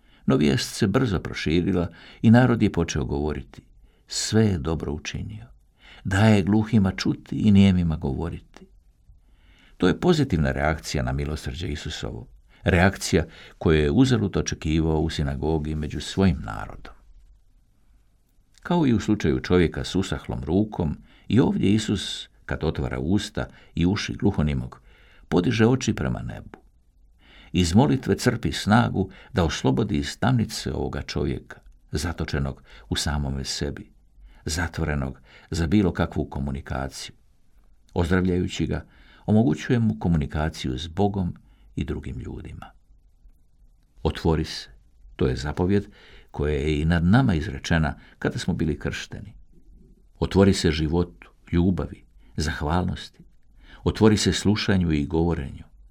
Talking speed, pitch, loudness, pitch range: 120 wpm, 85 Hz, -24 LUFS, 75-100 Hz